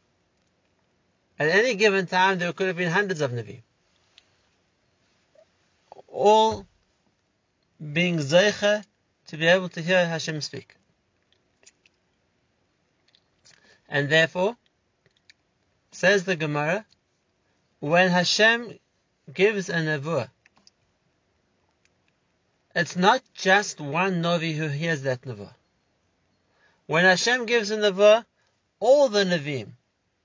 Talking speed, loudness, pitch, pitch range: 95 wpm, -22 LUFS, 175 Hz, 135-195 Hz